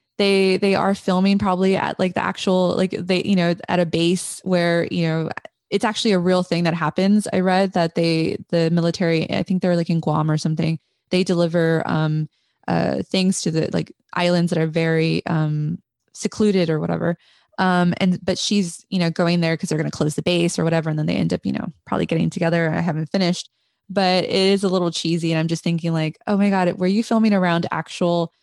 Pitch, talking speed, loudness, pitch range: 175 Hz, 220 wpm, -20 LUFS, 165-190 Hz